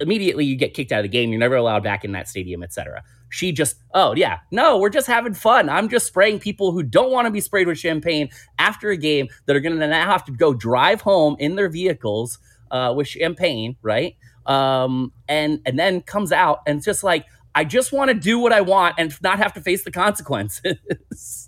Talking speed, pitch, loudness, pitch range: 230 wpm, 155 Hz, -19 LUFS, 125-195 Hz